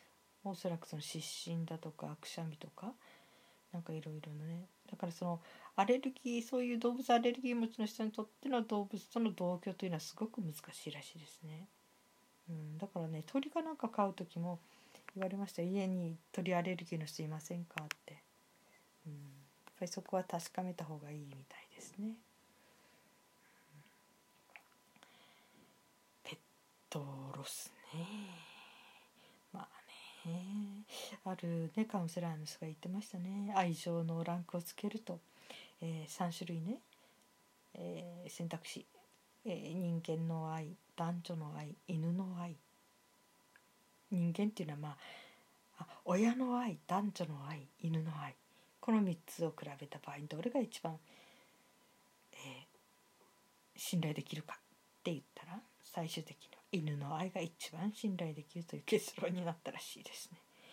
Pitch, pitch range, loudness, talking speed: 175 Hz, 160-205 Hz, -42 LUFS, 280 characters per minute